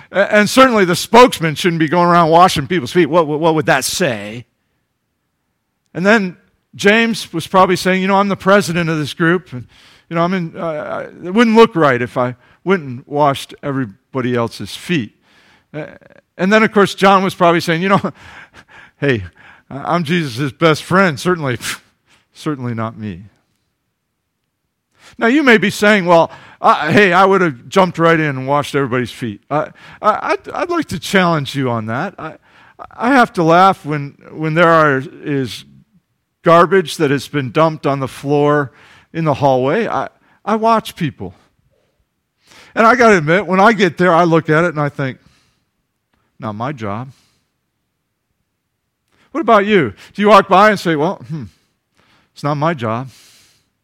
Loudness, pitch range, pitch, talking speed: -14 LUFS, 130-185 Hz, 160 Hz, 175 wpm